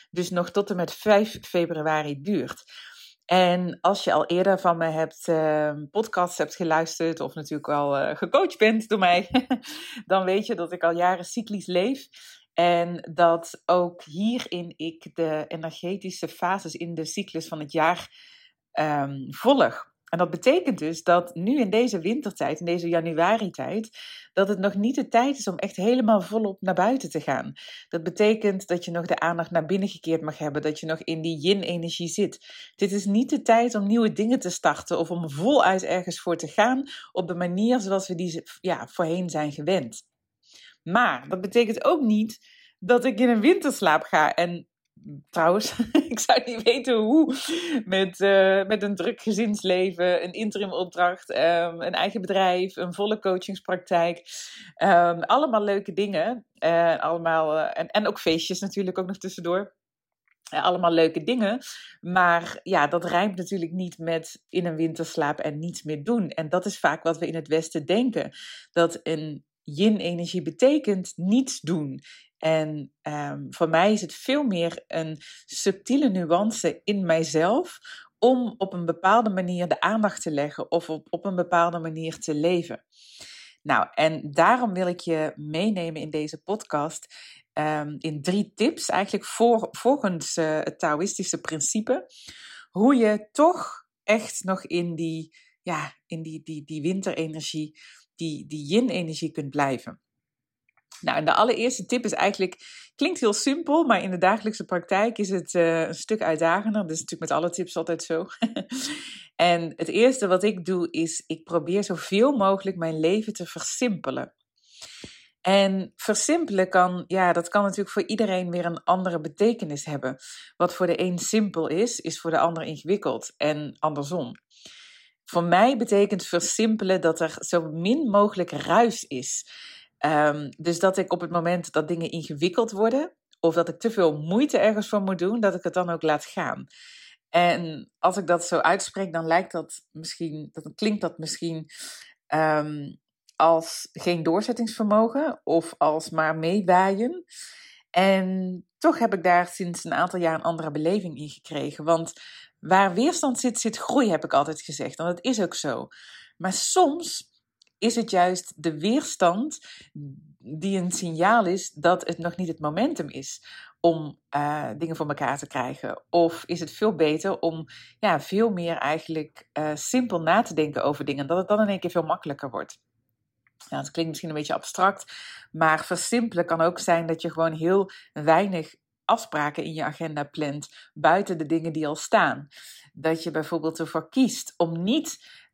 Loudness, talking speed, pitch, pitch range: -25 LUFS, 170 wpm, 180 Hz, 165-210 Hz